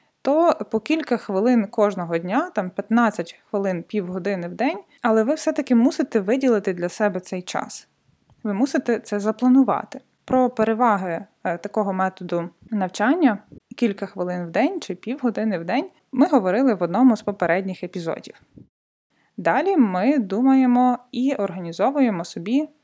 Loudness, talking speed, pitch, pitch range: -22 LUFS, 135 wpm, 220 Hz, 190-260 Hz